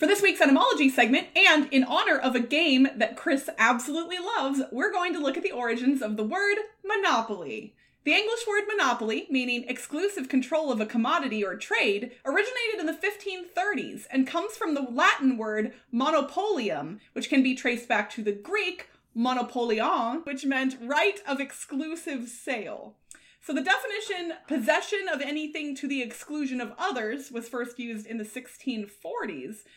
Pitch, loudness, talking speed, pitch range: 275 Hz, -26 LUFS, 165 wpm, 245-345 Hz